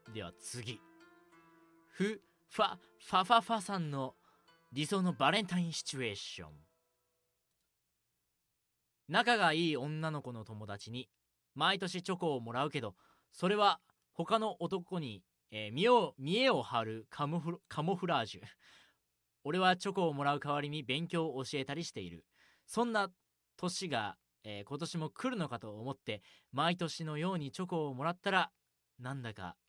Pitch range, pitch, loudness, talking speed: 125-180 Hz, 160 Hz, -35 LUFS, 285 characters per minute